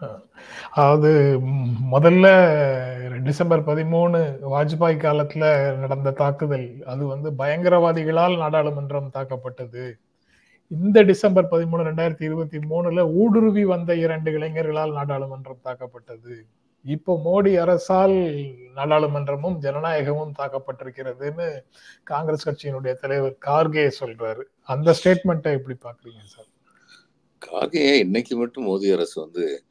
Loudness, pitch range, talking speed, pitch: -20 LUFS, 135-170 Hz, 85 wpm, 150 Hz